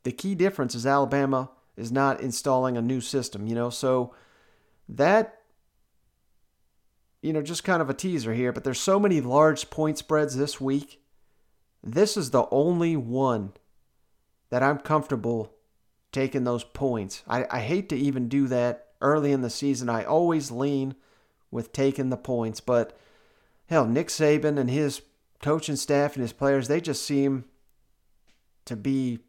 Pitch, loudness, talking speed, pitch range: 135 Hz, -26 LUFS, 160 wpm, 120-150 Hz